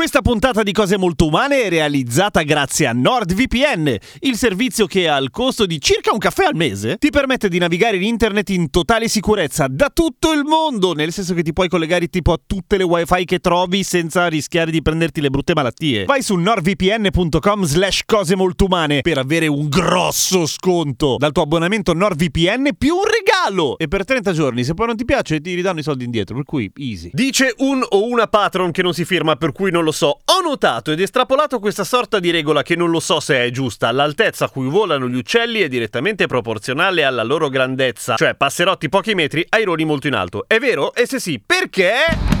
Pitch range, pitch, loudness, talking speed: 155-225 Hz, 180 Hz, -16 LUFS, 210 wpm